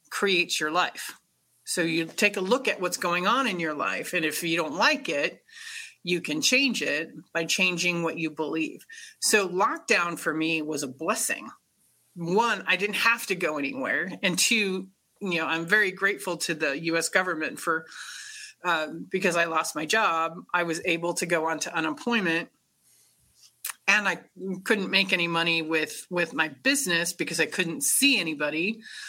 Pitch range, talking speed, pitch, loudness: 165-205 Hz, 175 wpm, 175 Hz, -25 LUFS